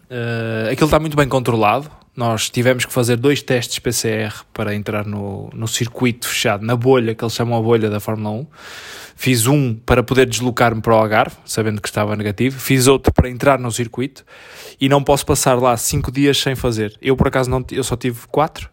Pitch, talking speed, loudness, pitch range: 125 Hz, 205 wpm, -17 LUFS, 110-130 Hz